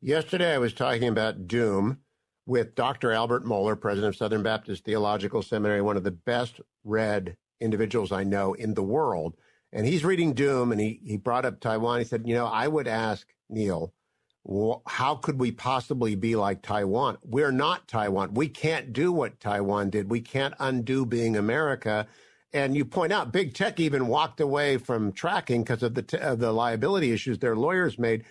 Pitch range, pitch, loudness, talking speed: 105-135 Hz, 115 Hz, -27 LUFS, 190 wpm